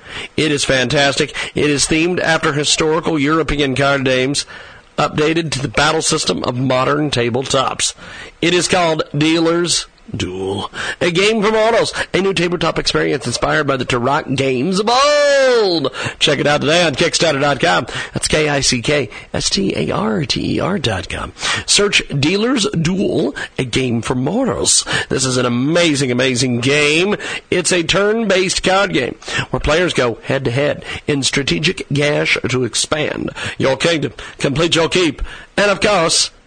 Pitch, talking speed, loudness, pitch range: 155 Hz, 140 wpm, -15 LUFS, 135-175 Hz